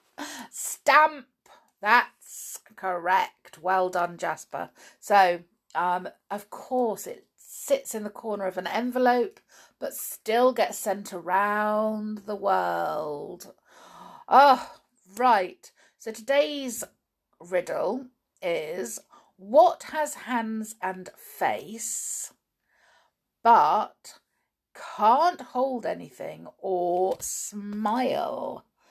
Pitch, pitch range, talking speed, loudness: 220 Hz, 190-265 Hz, 85 wpm, -26 LUFS